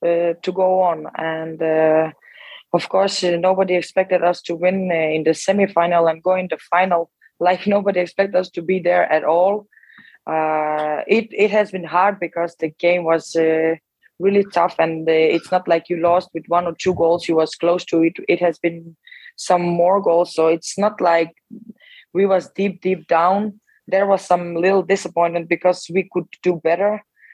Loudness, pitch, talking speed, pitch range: -18 LUFS, 175 Hz, 190 wpm, 165-190 Hz